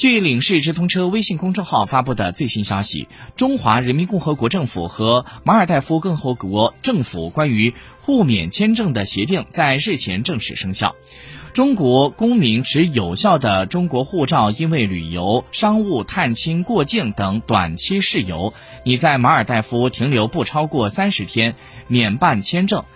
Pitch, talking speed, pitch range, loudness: 130 Hz, 255 characters per minute, 110-180 Hz, -17 LUFS